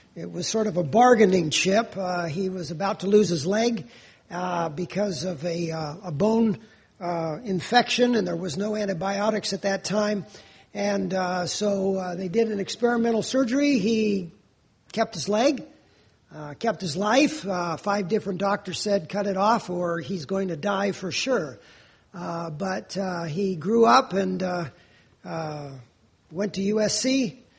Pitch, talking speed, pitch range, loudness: 195 Hz, 165 wpm, 175-215 Hz, -25 LUFS